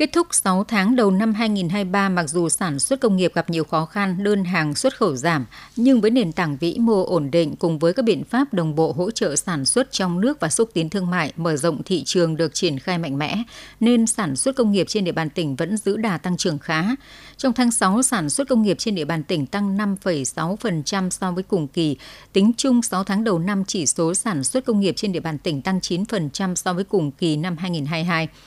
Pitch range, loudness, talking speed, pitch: 165-215 Hz, -21 LUFS, 240 wpm, 185 Hz